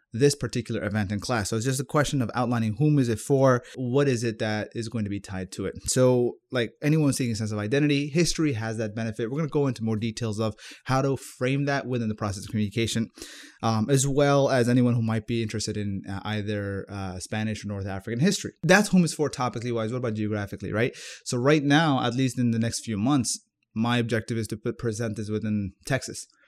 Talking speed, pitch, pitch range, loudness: 235 wpm, 115 Hz, 110-135 Hz, -26 LUFS